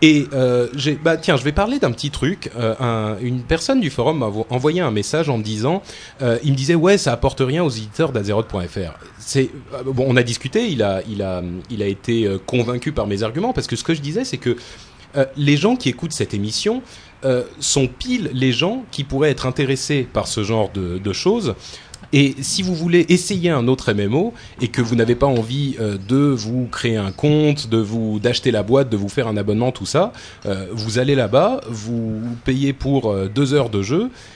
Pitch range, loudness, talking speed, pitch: 110-145 Hz, -19 LUFS, 215 wpm, 130 Hz